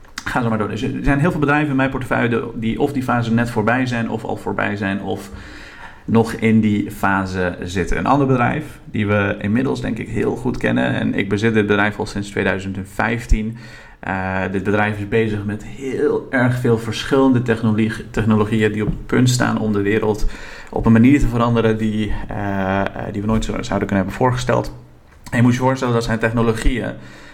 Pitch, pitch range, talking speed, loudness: 110 Hz, 100-120 Hz, 200 wpm, -19 LUFS